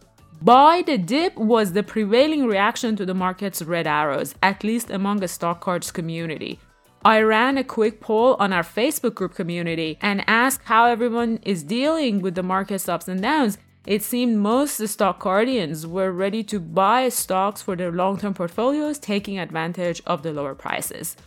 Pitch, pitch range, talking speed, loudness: 205 Hz, 185-235 Hz, 175 wpm, -21 LUFS